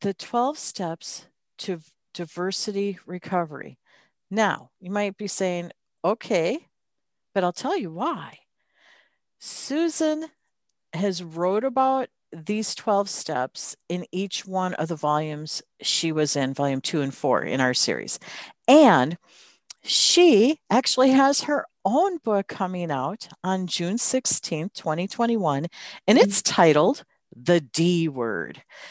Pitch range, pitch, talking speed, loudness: 160-225 Hz, 185 Hz, 120 wpm, -23 LUFS